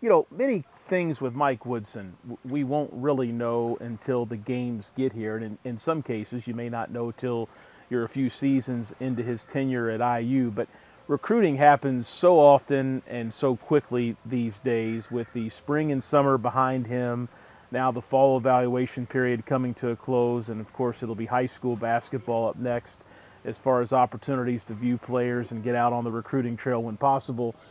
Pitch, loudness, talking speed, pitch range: 125 Hz, -26 LUFS, 190 wpm, 115-135 Hz